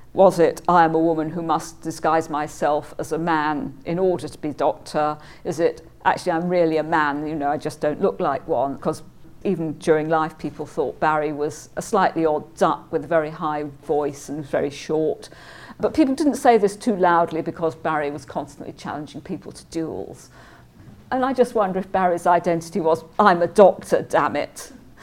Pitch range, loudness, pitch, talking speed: 150-175 Hz, -21 LUFS, 160 Hz, 195 wpm